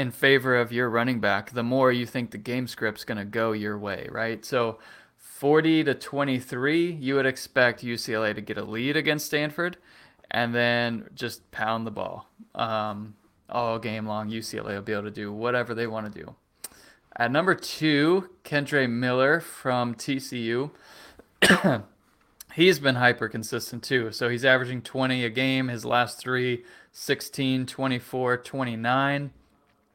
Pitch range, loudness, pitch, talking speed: 115-135 Hz, -26 LUFS, 125 Hz, 150 wpm